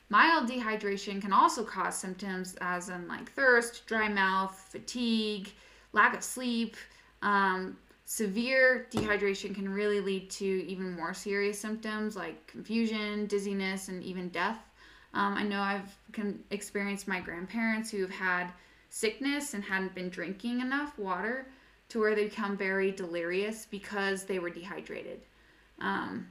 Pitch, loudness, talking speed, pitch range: 200 Hz, -32 LUFS, 140 wpm, 190-220 Hz